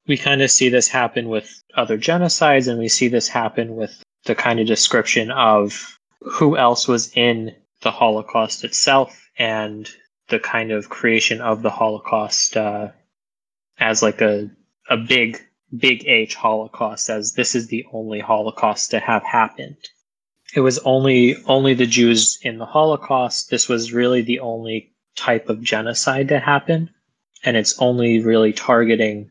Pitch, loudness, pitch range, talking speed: 115 Hz, -17 LUFS, 110-130 Hz, 160 wpm